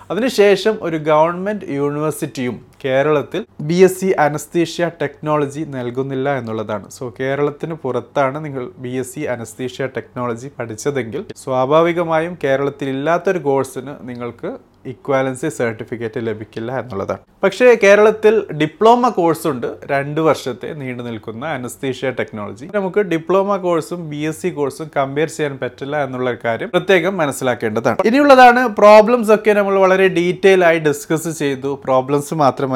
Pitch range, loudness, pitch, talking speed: 130-175 Hz, -16 LUFS, 145 Hz, 120 wpm